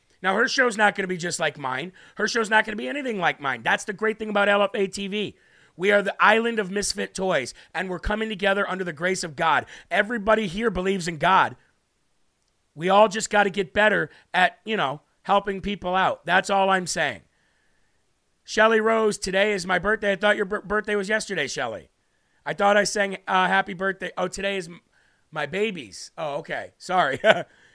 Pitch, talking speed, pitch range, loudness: 200 Hz, 195 wpm, 185-215 Hz, -23 LUFS